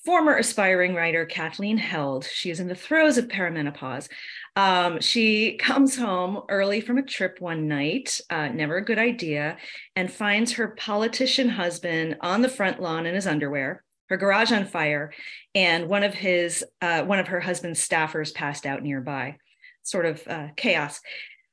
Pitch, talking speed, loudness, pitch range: 180 Hz, 160 wpm, -24 LUFS, 160-220 Hz